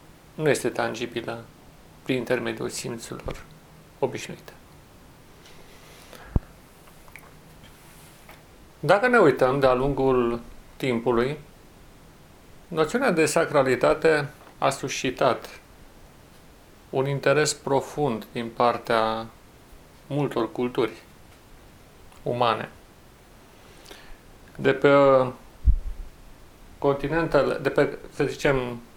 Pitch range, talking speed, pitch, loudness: 115-140 Hz, 70 wpm, 130 Hz, -24 LUFS